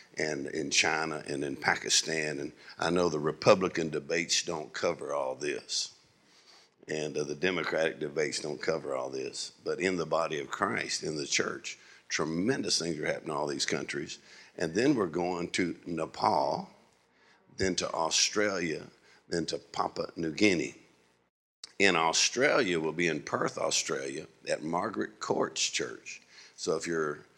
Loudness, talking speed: -30 LUFS, 155 wpm